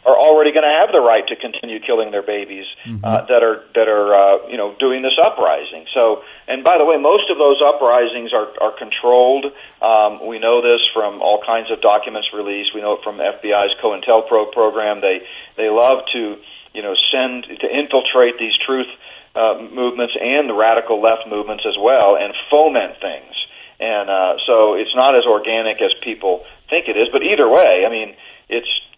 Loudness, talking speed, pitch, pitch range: -15 LUFS, 195 wpm, 115 Hz, 105-135 Hz